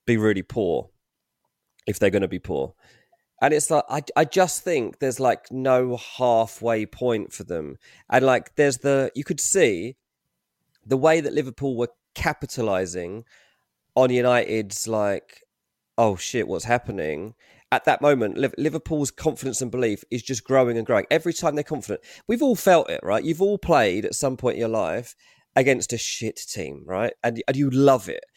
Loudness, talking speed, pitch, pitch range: -23 LUFS, 175 wpm, 130 Hz, 120-155 Hz